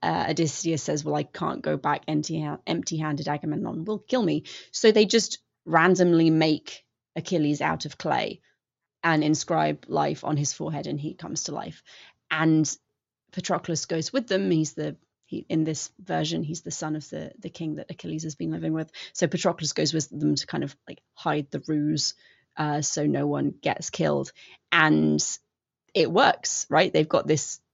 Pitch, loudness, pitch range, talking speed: 155 Hz, -26 LUFS, 145-165 Hz, 180 wpm